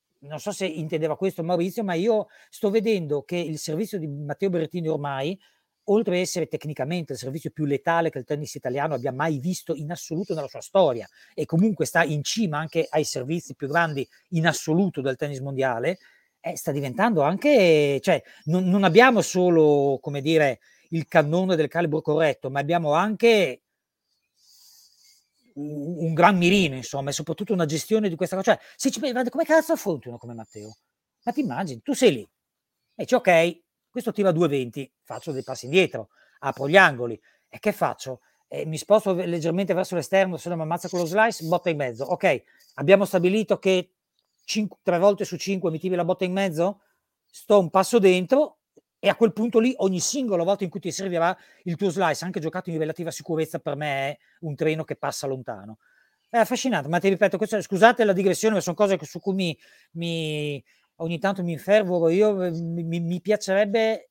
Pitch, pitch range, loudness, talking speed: 175 Hz, 155-195 Hz, -23 LUFS, 185 wpm